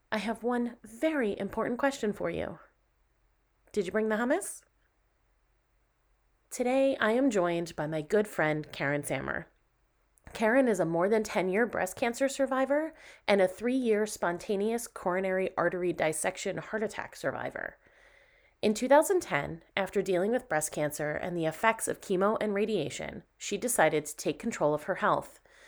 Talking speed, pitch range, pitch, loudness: 155 wpm, 180-245 Hz, 210 Hz, -30 LUFS